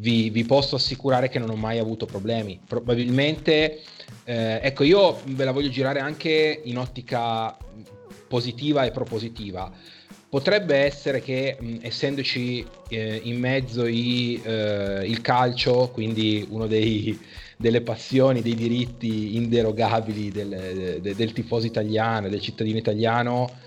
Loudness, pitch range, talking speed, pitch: -24 LUFS, 110-130 Hz, 130 wpm, 120 Hz